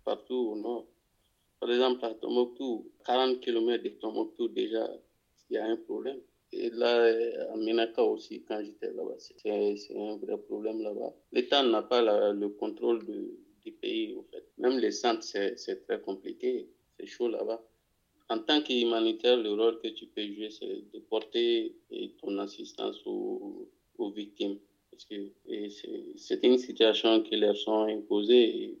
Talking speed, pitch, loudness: 170 wpm, 335 Hz, -31 LUFS